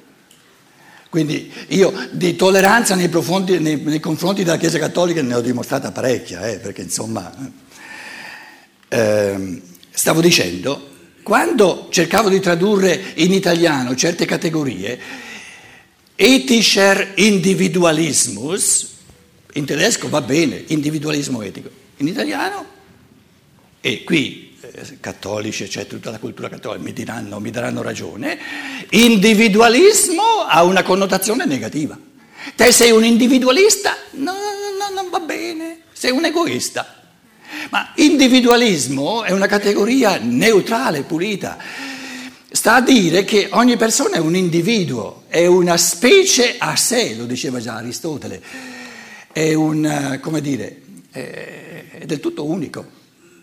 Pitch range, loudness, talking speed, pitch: 160-245 Hz, -15 LUFS, 120 wpm, 190 Hz